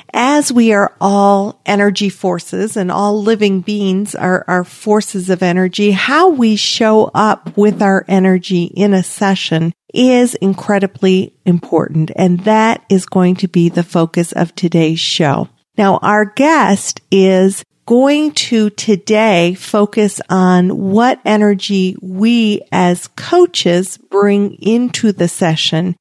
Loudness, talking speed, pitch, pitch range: -12 LUFS, 130 wpm, 195 Hz, 185-215 Hz